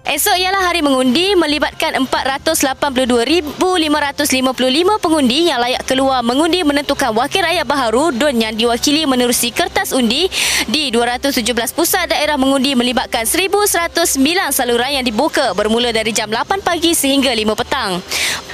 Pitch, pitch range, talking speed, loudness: 280 Hz, 250-335 Hz, 125 wpm, -14 LUFS